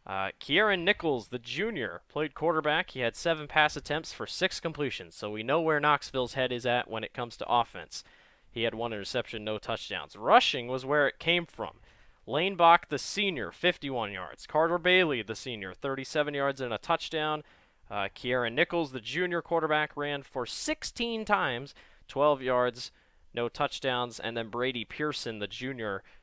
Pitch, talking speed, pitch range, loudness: 140 Hz, 170 wpm, 120-165 Hz, -30 LUFS